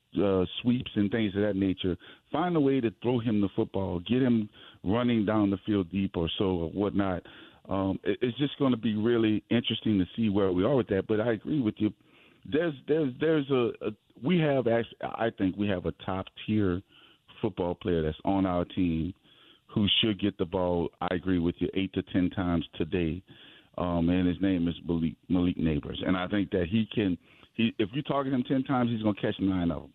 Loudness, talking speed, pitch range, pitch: -29 LUFS, 220 wpm, 90-115 Hz, 100 Hz